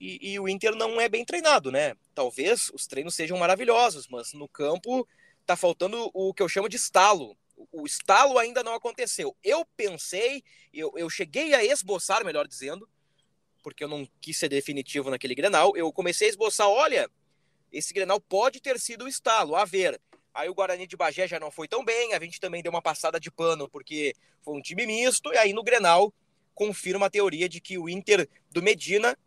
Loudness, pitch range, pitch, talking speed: -26 LUFS, 165-245 Hz, 195 Hz, 200 wpm